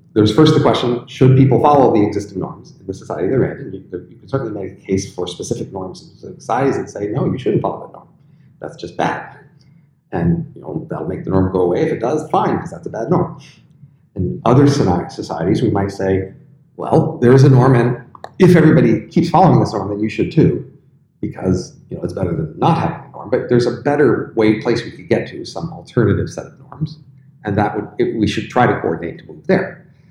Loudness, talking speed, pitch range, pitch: -16 LUFS, 225 wpm, 110-150 Hz, 130 Hz